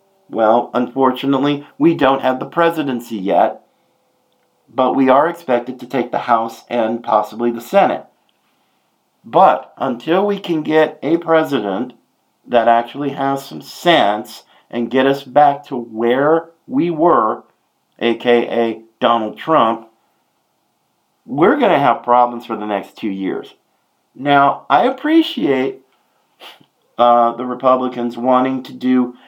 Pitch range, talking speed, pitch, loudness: 120-145 Hz, 125 wpm, 130 Hz, -16 LUFS